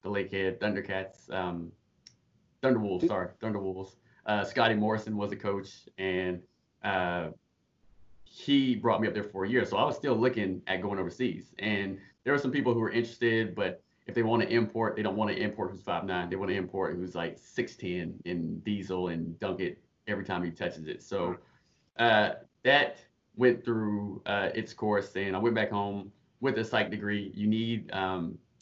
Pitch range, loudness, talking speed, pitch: 95-110 Hz, -31 LUFS, 190 wpm, 100 Hz